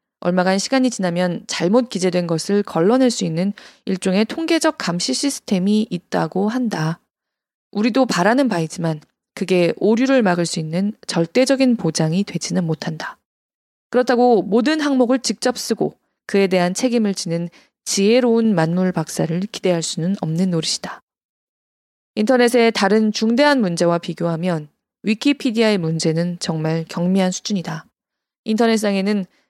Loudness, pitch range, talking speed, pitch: -18 LUFS, 170-235 Hz, 315 characters per minute, 195 Hz